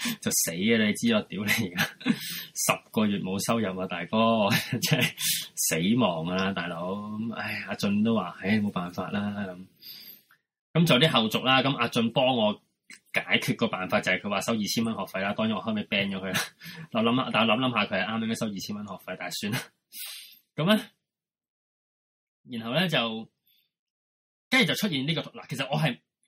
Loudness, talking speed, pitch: -26 LUFS, 260 characters per minute, 125 Hz